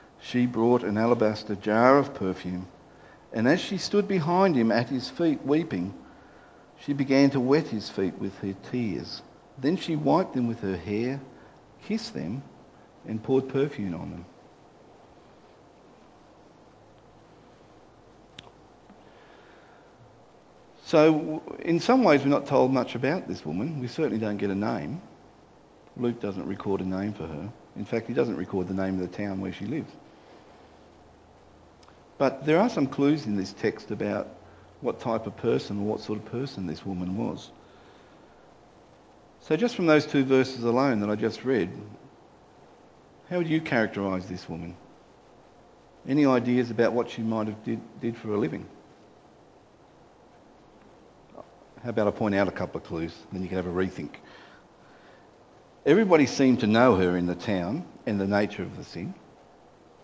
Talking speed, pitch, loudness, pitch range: 155 wpm, 110 Hz, -26 LUFS, 95-135 Hz